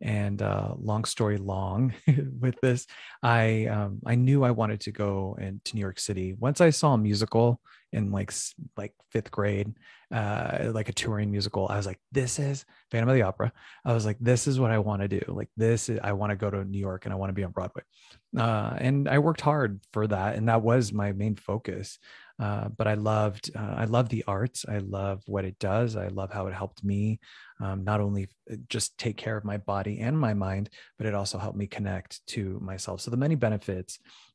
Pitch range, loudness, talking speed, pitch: 100-120 Hz, -28 LUFS, 225 wpm, 105 Hz